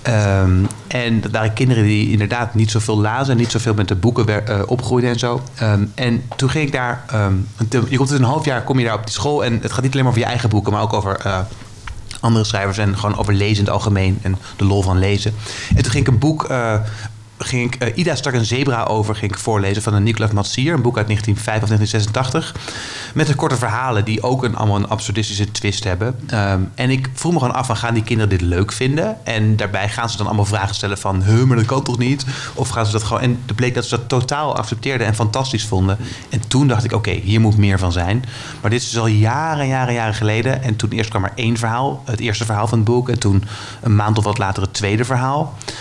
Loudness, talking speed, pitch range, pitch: -18 LUFS, 255 wpm, 105-125 Hz, 110 Hz